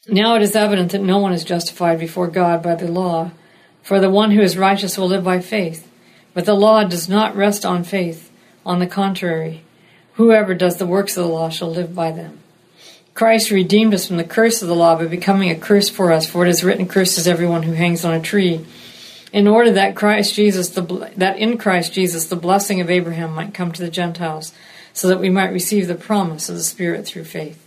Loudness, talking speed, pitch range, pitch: -16 LUFS, 225 wpm, 170-200 Hz, 180 Hz